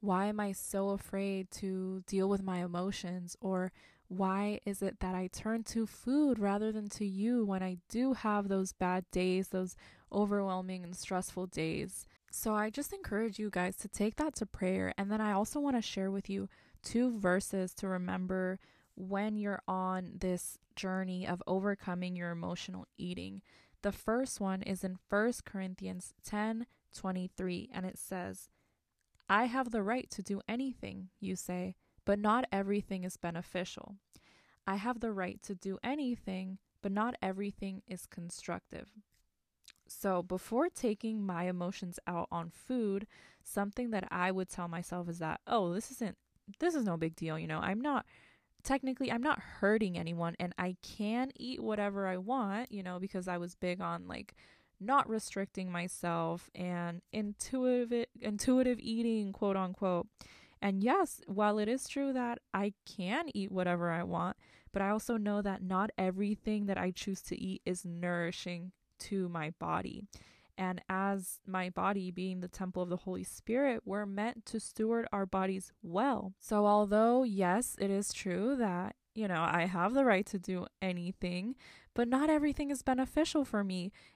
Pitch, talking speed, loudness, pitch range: 195 Hz, 170 wpm, -36 LUFS, 185-220 Hz